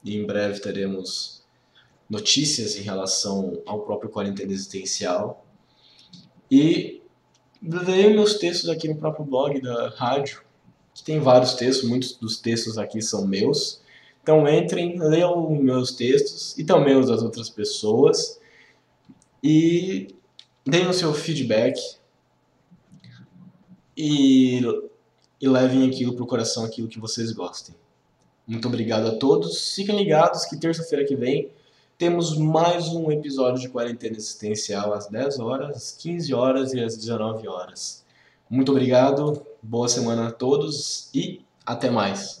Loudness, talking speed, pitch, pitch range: -22 LUFS, 135 wpm, 130 Hz, 115-165 Hz